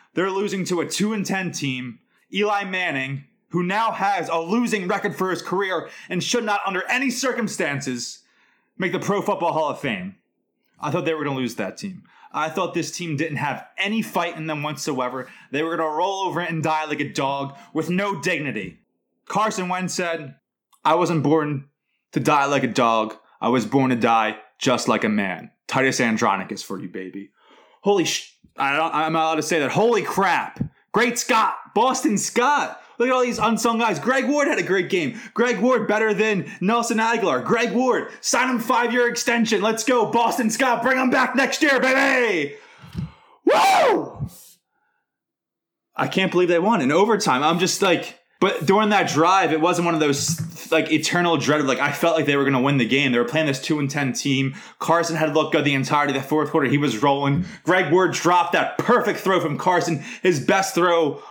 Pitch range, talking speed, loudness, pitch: 150-220 Hz, 200 wpm, -21 LUFS, 175 Hz